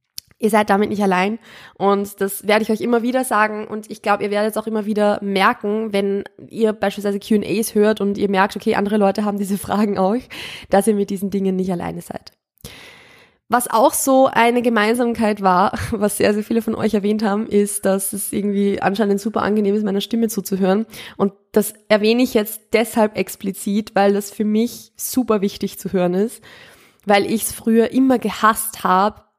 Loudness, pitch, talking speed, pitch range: -18 LUFS, 210 Hz, 190 wpm, 200-220 Hz